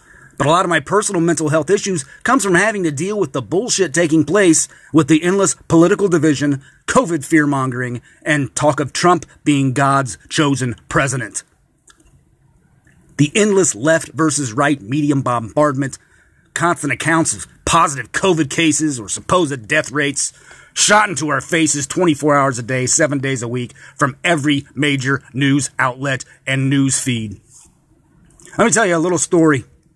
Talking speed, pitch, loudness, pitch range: 155 wpm, 150 Hz, -16 LUFS, 135-165 Hz